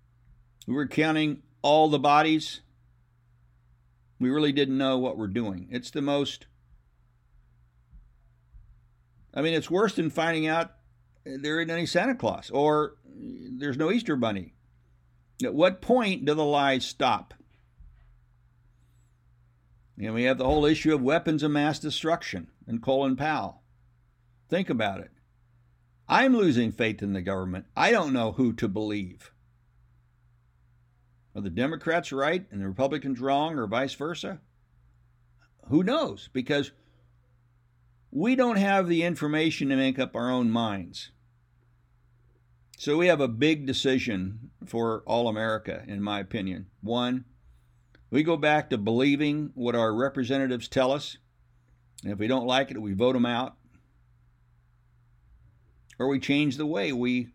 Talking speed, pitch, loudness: 140 wpm, 120 Hz, -27 LUFS